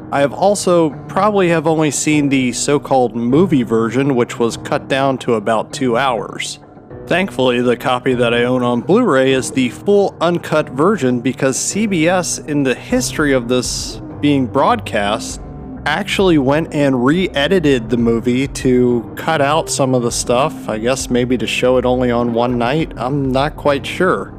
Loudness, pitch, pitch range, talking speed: -15 LUFS, 130 Hz, 120-150 Hz, 165 wpm